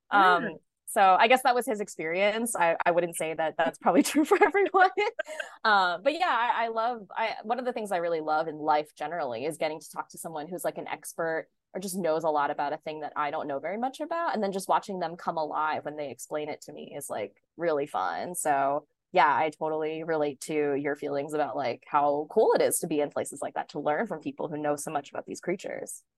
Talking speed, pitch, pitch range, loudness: 250 wpm, 165 Hz, 150-225 Hz, -28 LUFS